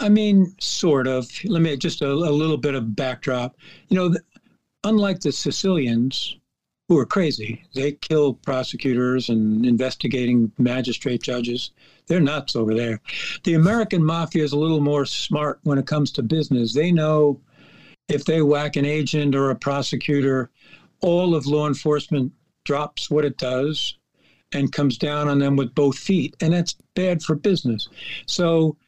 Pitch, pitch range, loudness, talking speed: 145 Hz, 130-165 Hz, -21 LUFS, 160 wpm